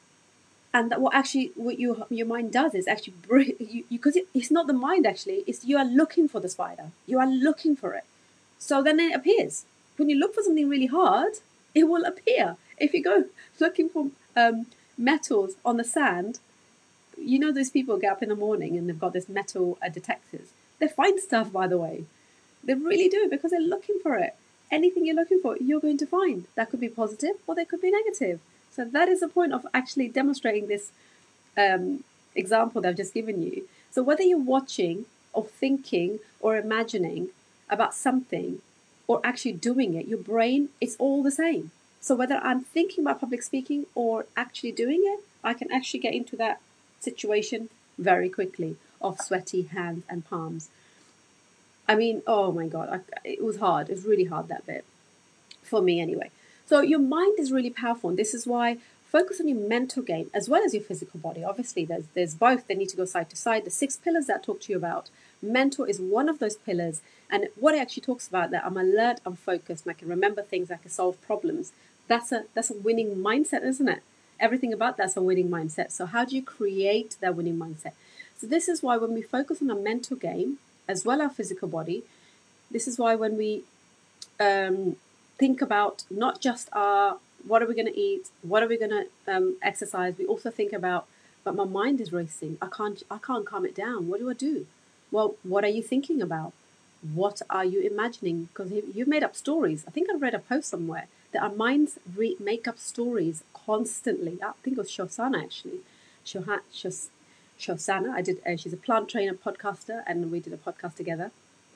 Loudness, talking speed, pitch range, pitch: -27 LUFS, 205 wpm, 200-295 Hz, 235 Hz